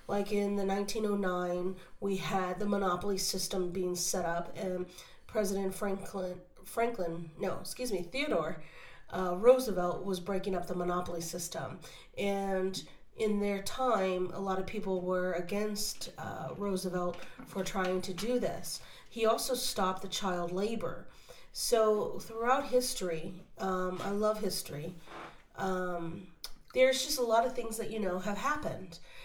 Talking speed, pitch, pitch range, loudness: 145 wpm, 190 Hz, 180-215 Hz, -34 LUFS